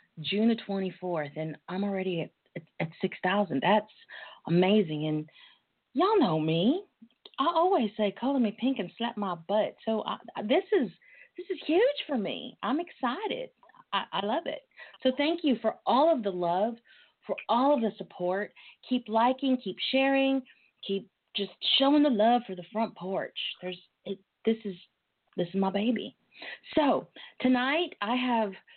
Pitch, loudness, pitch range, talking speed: 220 Hz, -29 LUFS, 190-270 Hz, 170 wpm